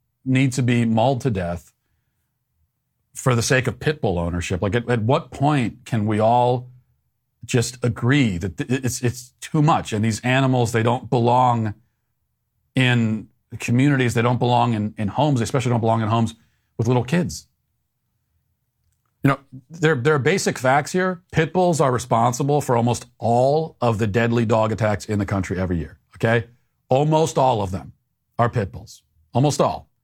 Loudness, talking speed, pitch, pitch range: -20 LUFS, 170 wpm, 120 Hz, 115-135 Hz